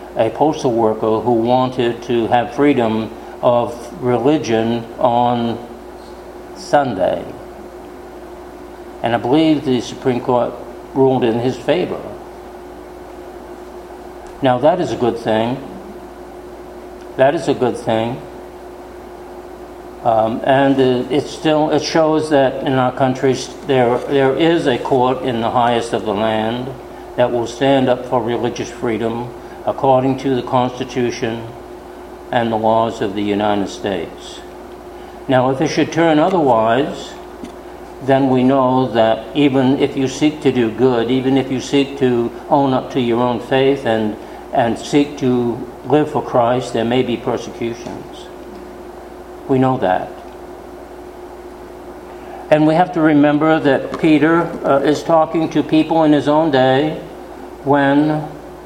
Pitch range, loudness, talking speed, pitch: 120-150 Hz, -16 LUFS, 135 wpm, 130 Hz